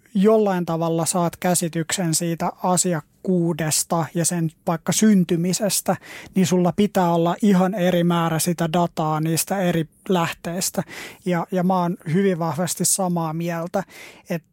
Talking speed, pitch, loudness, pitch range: 130 wpm, 175 Hz, -21 LUFS, 165-185 Hz